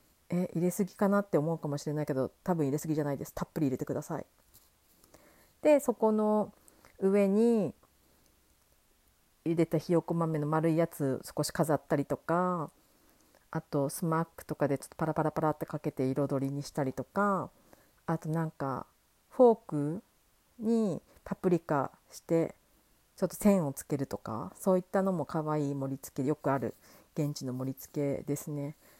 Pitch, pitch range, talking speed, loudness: 155 Hz, 145-180 Hz, 325 characters per minute, -32 LUFS